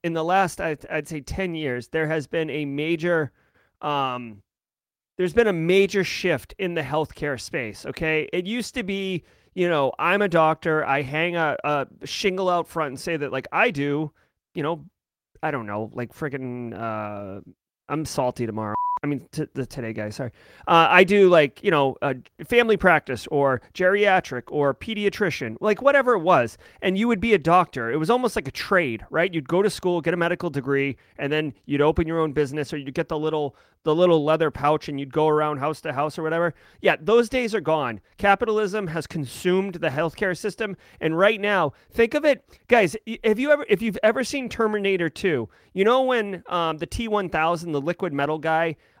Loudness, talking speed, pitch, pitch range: -23 LUFS, 200 wpm, 160 Hz, 145-195 Hz